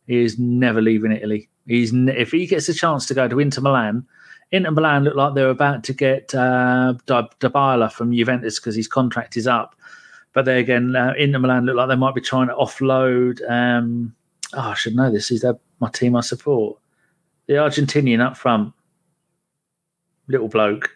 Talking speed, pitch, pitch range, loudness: 190 wpm, 130 Hz, 120-140 Hz, -19 LUFS